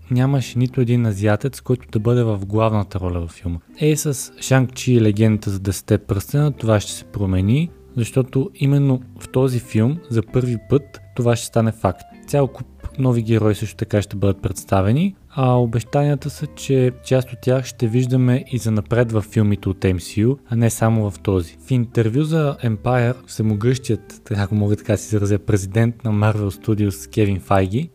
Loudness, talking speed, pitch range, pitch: -20 LUFS, 180 wpm, 105-130 Hz, 115 Hz